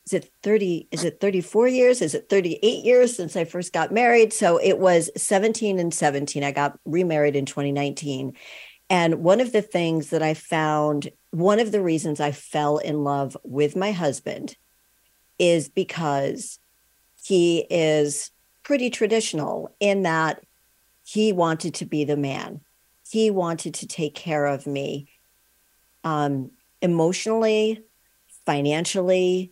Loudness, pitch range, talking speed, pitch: -22 LUFS, 145-195 Hz, 140 wpm, 165 Hz